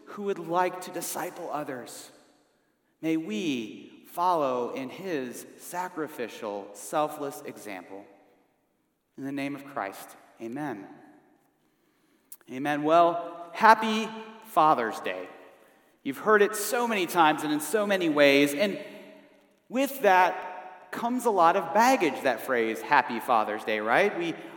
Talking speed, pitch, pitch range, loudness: 125 wpm, 180 Hz, 145-220 Hz, -26 LUFS